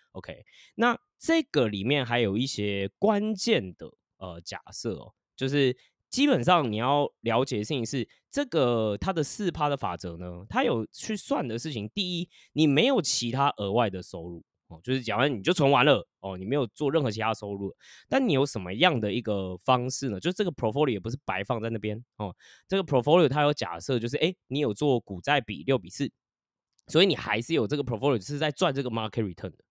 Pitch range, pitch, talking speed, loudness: 105-150 Hz, 130 Hz, 360 characters per minute, -27 LUFS